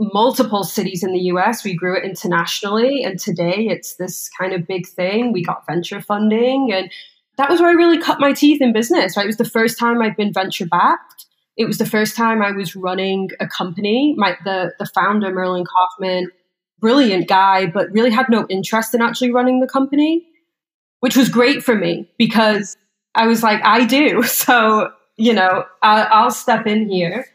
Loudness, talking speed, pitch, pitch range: -16 LUFS, 195 wpm, 210 Hz, 185-235 Hz